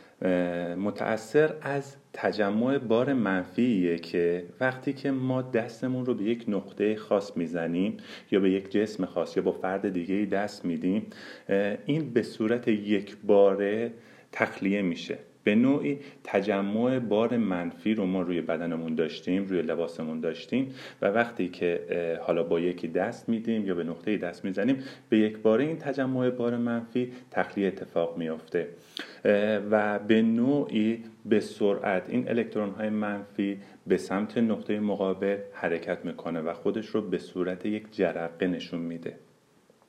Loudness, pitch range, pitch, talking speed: -28 LUFS, 90-115 Hz, 105 Hz, 140 wpm